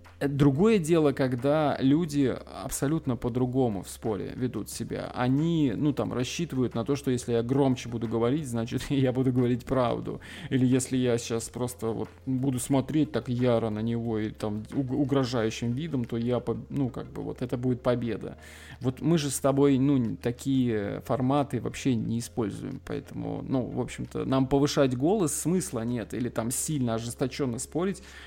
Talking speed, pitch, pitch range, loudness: 165 wpm, 130 Hz, 115-140 Hz, -28 LUFS